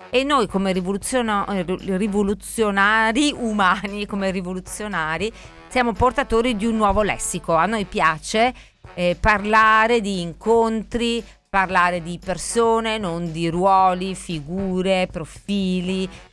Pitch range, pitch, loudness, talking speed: 180-220 Hz, 195 Hz, -20 LUFS, 105 wpm